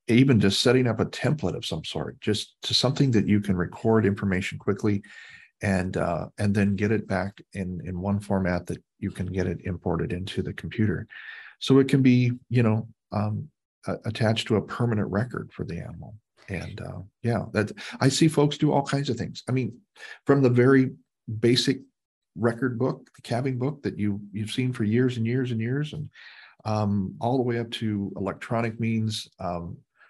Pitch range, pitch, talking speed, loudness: 100-125 Hz, 110 Hz, 190 wpm, -26 LUFS